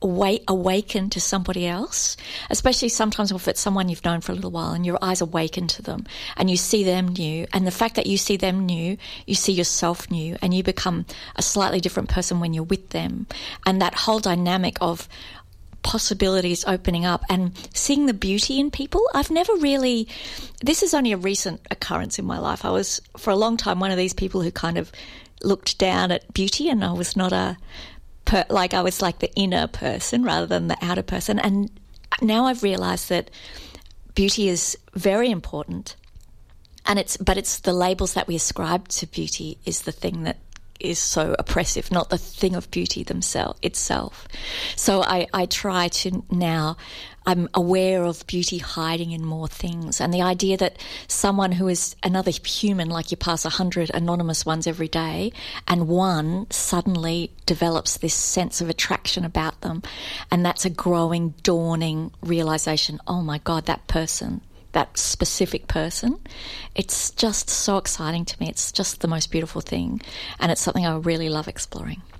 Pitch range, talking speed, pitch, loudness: 170-195 Hz, 180 wpm, 180 Hz, -23 LUFS